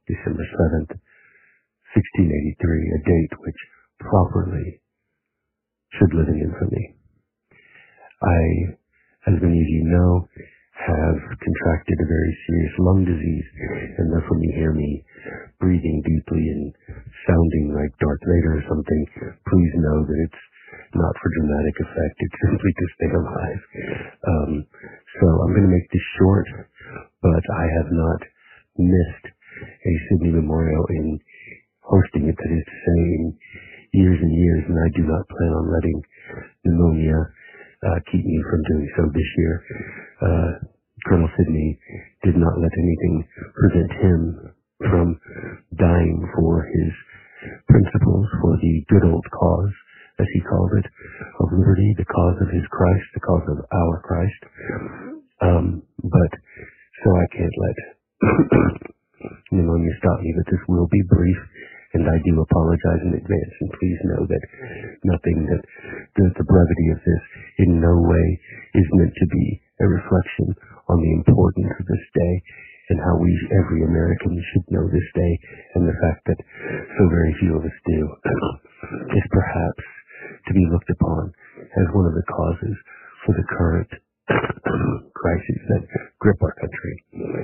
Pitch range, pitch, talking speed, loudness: 80-90 Hz, 85 Hz, 145 wpm, -20 LUFS